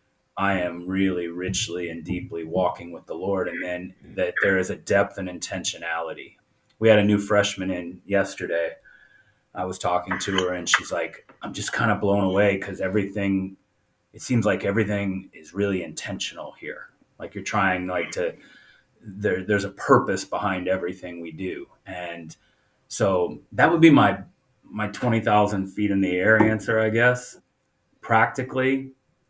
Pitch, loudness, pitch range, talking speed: 100 Hz, -23 LUFS, 90-105 Hz, 160 wpm